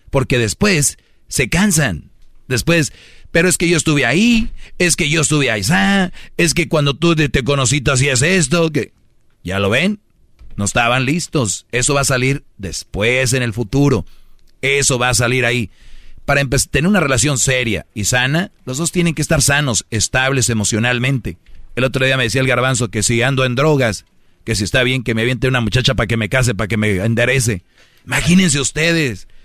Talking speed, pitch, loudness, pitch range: 185 wpm, 130 Hz, -15 LUFS, 115-150 Hz